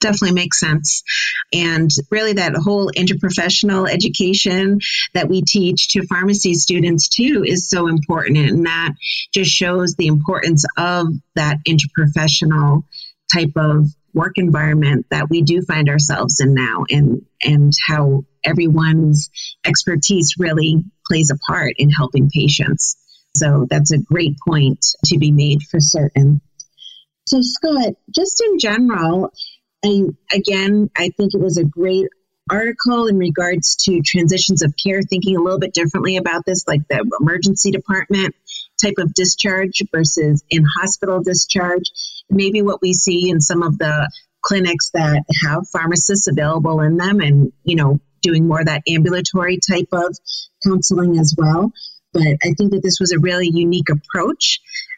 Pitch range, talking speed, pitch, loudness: 155-190 Hz, 150 wpm, 170 Hz, -15 LUFS